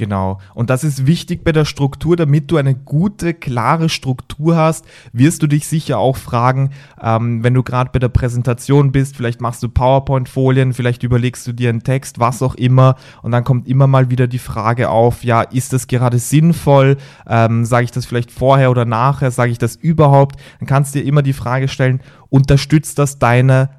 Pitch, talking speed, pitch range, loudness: 130 Hz, 200 wpm, 120-140 Hz, -14 LUFS